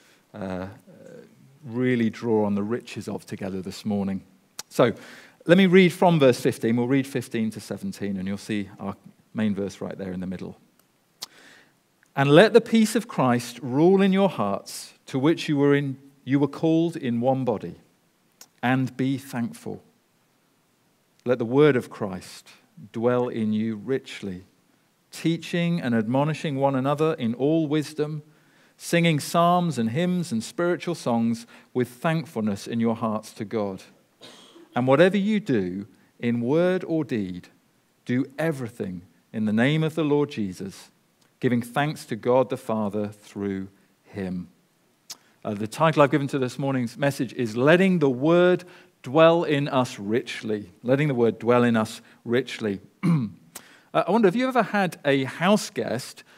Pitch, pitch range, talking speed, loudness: 130 Hz, 110-155 Hz, 155 wpm, -24 LUFS